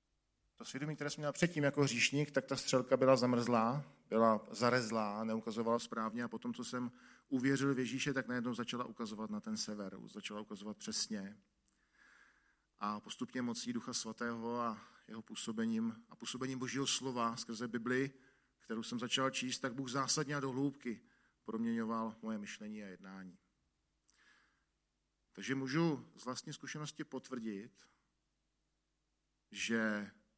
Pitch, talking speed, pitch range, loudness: 125 Hz, 140 wpm, 110-135 Hz, -38 LUFS